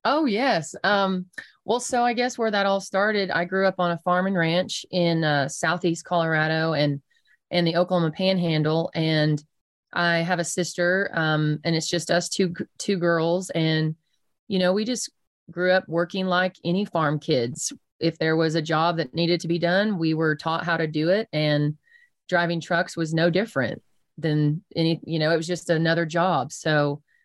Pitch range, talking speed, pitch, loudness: 160-185 Hz, 190 wpm, 170 Hz, -24 LUFS